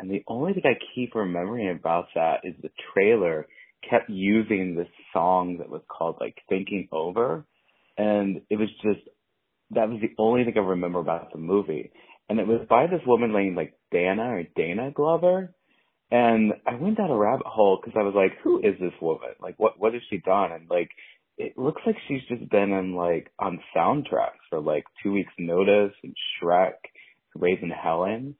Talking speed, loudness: 190 wpm, -25 LUFS